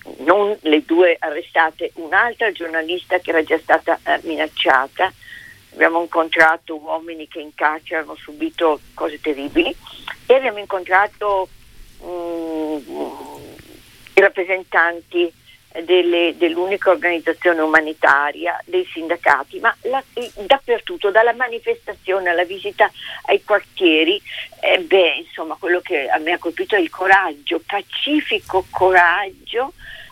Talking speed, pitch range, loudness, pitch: 115 wpm, 165-210 Hz, -18 LUFS, 180 Hz